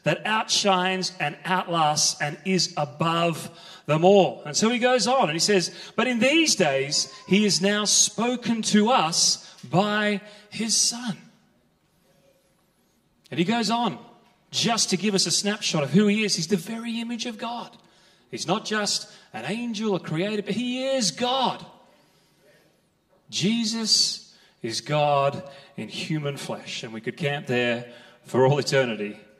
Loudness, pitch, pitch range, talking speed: -23 LUFS, 185 Hz, 170-215 Hz, 155 wpm